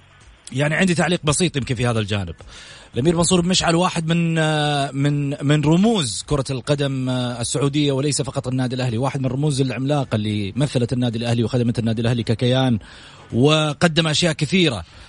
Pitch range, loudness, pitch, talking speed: 120-155 Hz, -20 LUFS, 140 Hz, 155 wpm